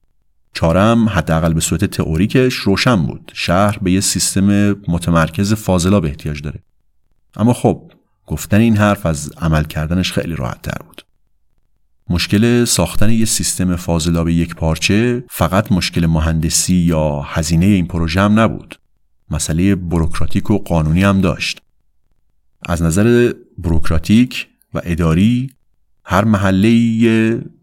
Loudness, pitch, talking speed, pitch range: -15 LUFS, 95 Hz, 125 wpm, 80-105 Hz